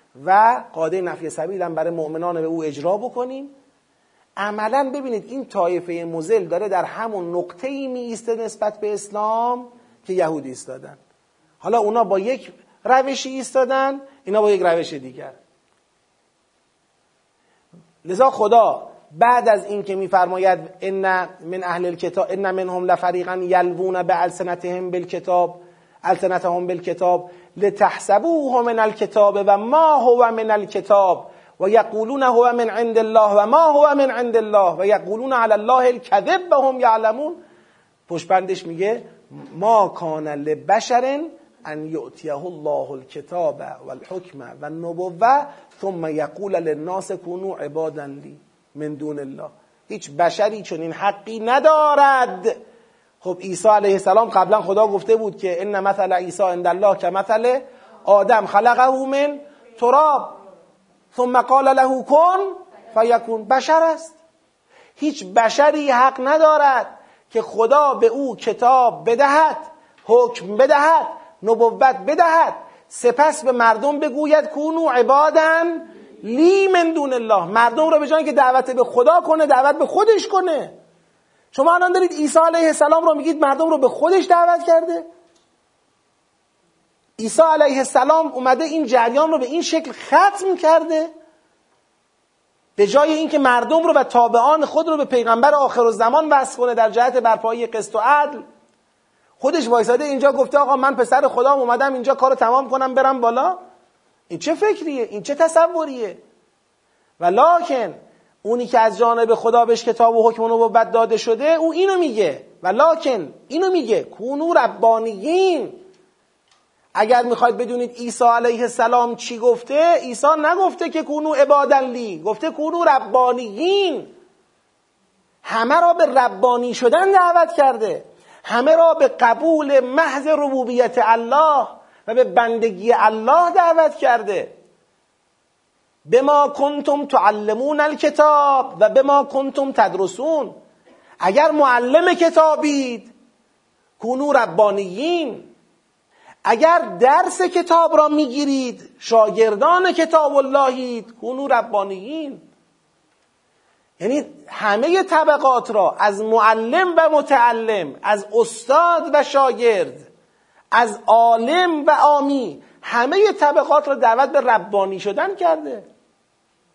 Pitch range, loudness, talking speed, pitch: 210-305 Hz, -17 LUFS, 130 wpm, 250 Hz